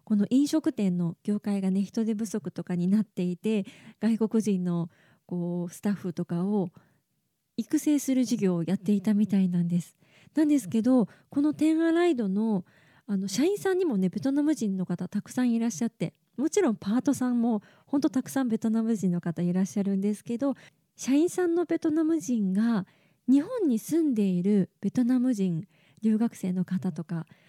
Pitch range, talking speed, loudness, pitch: 185-255 Hz, 350 characters per minute, -27 LUFS, 210 Hz